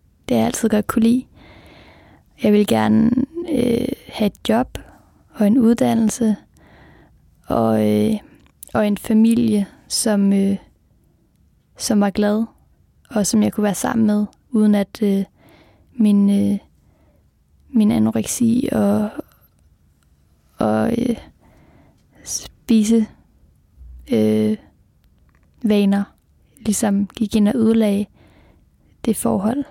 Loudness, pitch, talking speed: -18 LUFS, 205 Hz, 105 wpm